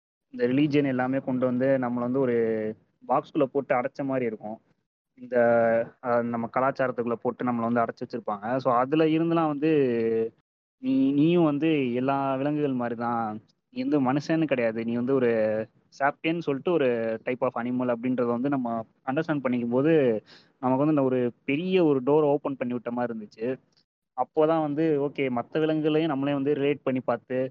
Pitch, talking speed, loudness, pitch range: 130 Hz, 160 wpm, -26 LUFS, 120-150 Hz